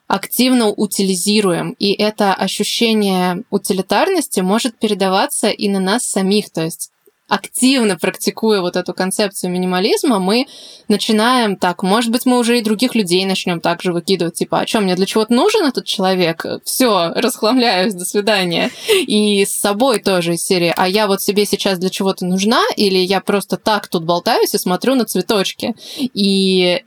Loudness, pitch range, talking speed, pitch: -15 LUFS, 190-230 Hz, 160 wpm, 205 Hz